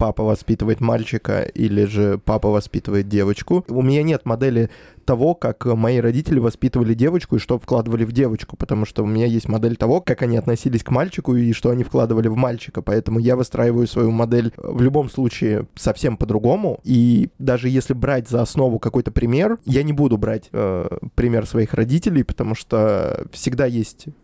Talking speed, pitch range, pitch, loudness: 175 wpm, 110-130 Hz, 115 Hz, -19 LUFS